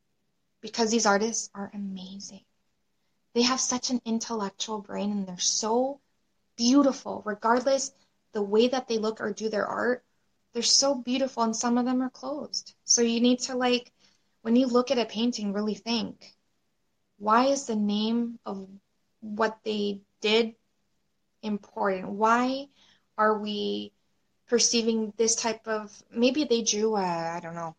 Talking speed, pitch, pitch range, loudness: 150 wpm, 225 Hz, 205-245 Hz, -27 LUFS